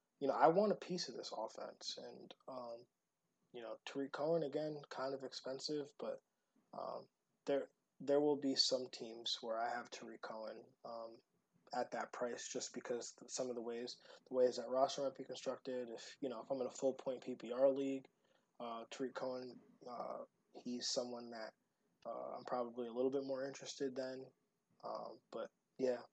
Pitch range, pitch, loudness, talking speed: 120-135 Hz, 130 Hz, -43 LUFS, 180 wpm